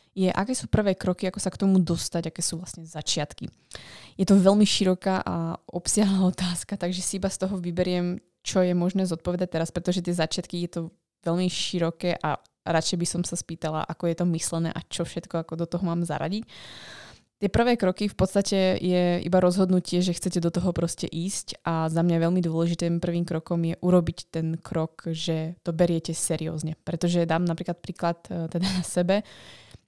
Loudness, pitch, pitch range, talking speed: -26 LUFS, 175 Hz, 165-185 Hz, 185 wpm